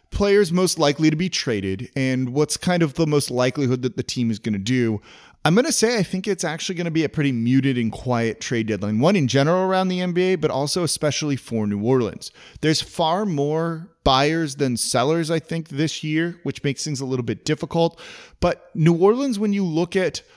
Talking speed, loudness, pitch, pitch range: 220 wpm, -21 LUFS, 155 Hz, 130-175 Hz